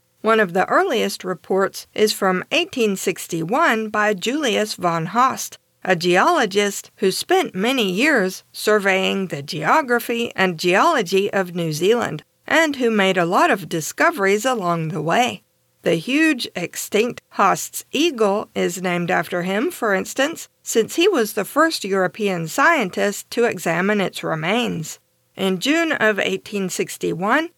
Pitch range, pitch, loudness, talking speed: 185-240 Hz, 205 Hz, -19 LUFS, 135 wpm